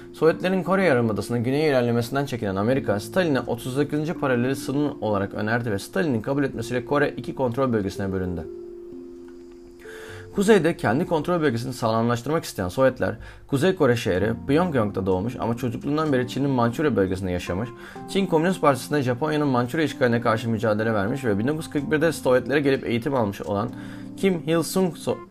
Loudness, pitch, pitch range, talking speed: -23 LUFS, 130 Hz, 110-150 Hz, 145 wpm